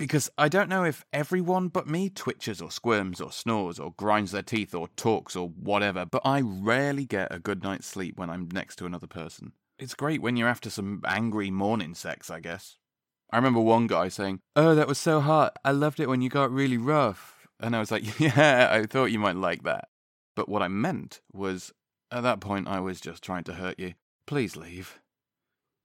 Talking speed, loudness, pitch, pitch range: 215 wpm, -27 LUFS, 110 Hz, 95-140 Hz